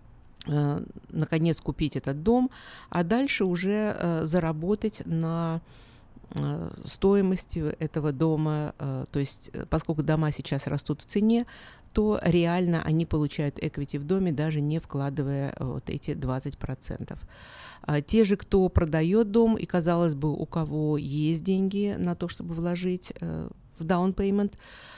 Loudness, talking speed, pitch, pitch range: -27 LUFS, 125 wpm, 160 Hz, 145-180 Hz